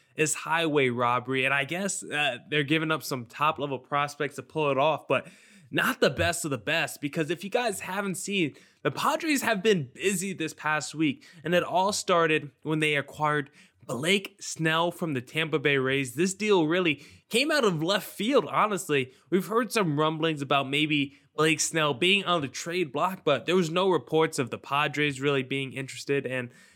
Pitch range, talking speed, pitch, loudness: 140-175 Hz, 195 wpm, 155 Hz, -27 LUFS